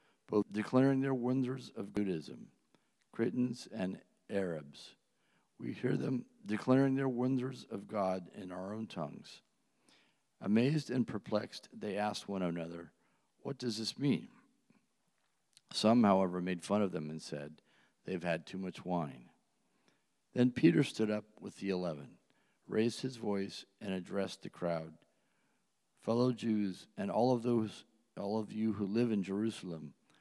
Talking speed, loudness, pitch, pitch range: 145 wpm, -36 LUFS, 105 Hz, 95-125 Hz